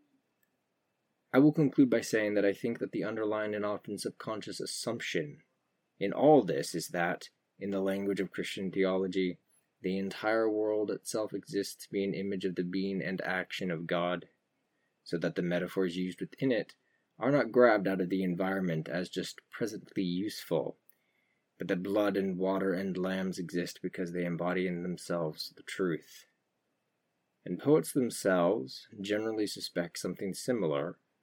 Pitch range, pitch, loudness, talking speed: 90-105 Hz, 95 Hz, -32 LUFS, 160 wpm